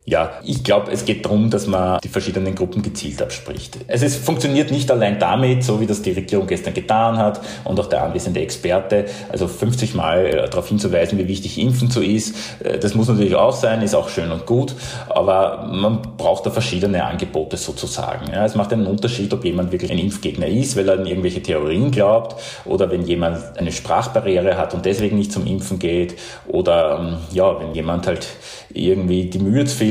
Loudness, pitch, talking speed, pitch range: -19 LUFS, 105 Hz, 195 wpm, 95-115 Hz